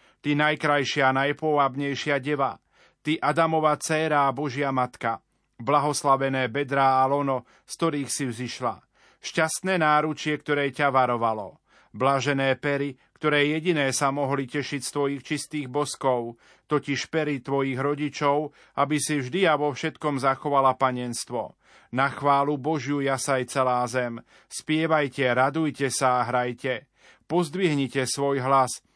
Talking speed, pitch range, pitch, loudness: 125 wpm, 130-150 Hz, 140 Hz, -25 LUFS